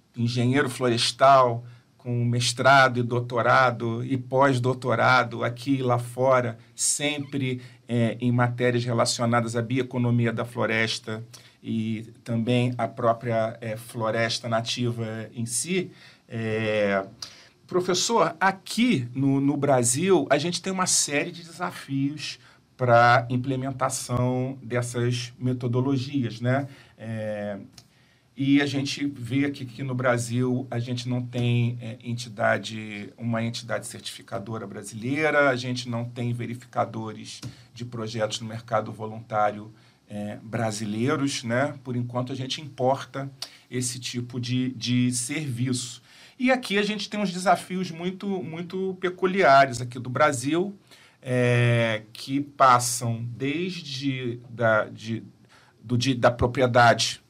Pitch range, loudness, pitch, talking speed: 115-135 Hz, -25 LUFS, 125 Hz, 120 wpm